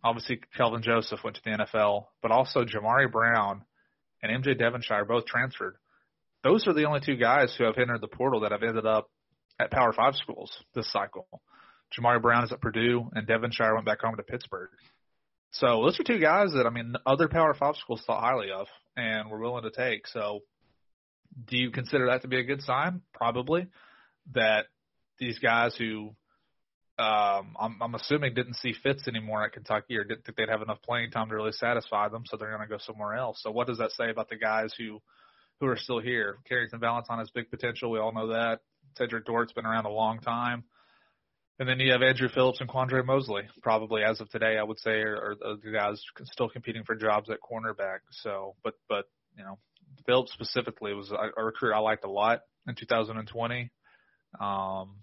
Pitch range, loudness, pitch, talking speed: 110-125 Hz, -29 LUFS, 115 Hz, 205 wpm